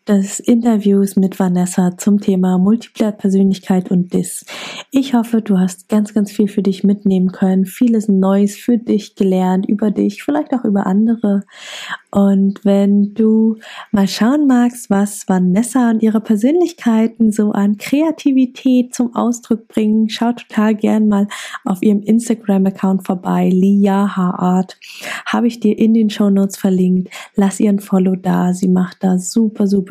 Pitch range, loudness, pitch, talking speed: 195-225 Hz, -15 LUFS, 205 Hz, 145 wpm